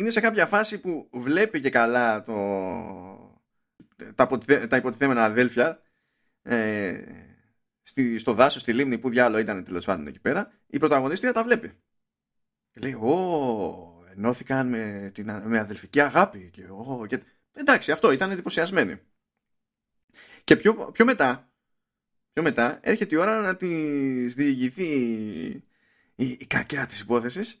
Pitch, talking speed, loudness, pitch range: 130 Hz, 125 wpm, -24 LUFS, 115-175 Hz